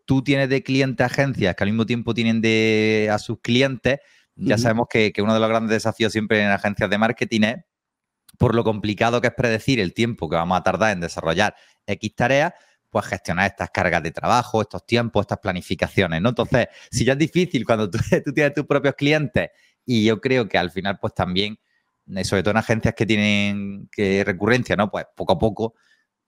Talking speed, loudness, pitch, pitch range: 205 wpm, -21 LUFS, 110 Hz, 100-120 Hz